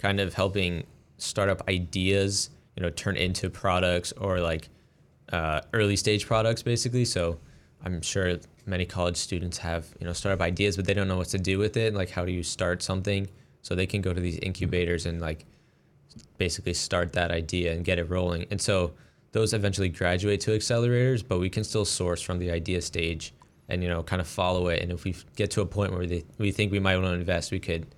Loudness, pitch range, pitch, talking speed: -28 LUFS, 85-100 Hz, 90 Hz, 215 wpm